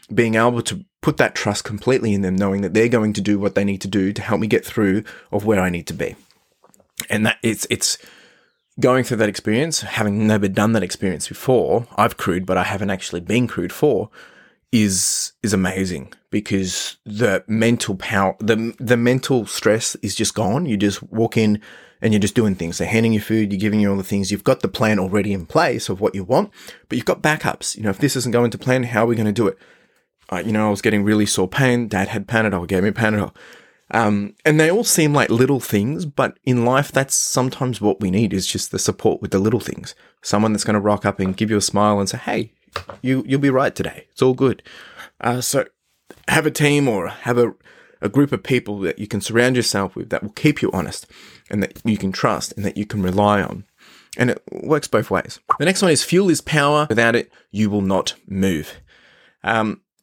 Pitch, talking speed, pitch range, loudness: 110 Hz, 230 wpm, 100-125 Hz, -19 LUFS